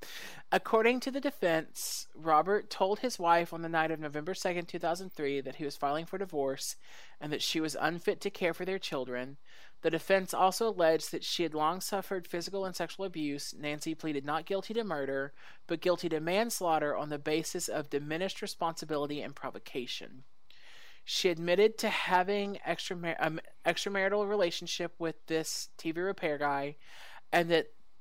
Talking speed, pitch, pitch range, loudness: 165 wpm, 170 Hz, 155-195 Hz, -33 LUFS